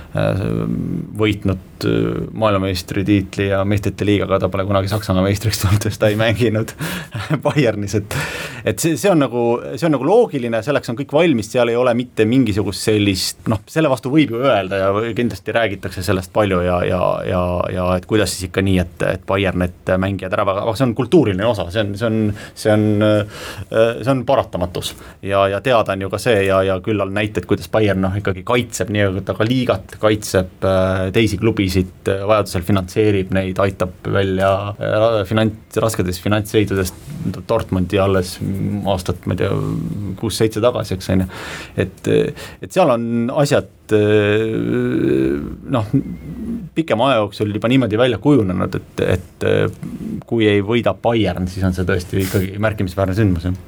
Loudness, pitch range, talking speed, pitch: -18 LUFS, 95-115 Hz, 160 wpm, 105 Hz